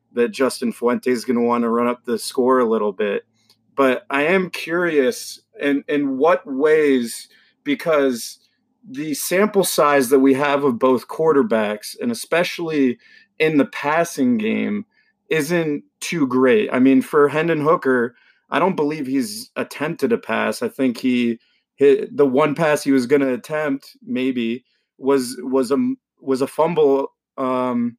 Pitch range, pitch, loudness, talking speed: 130-175 Hz, 140 Hz, -19 LUFS, 160 wpm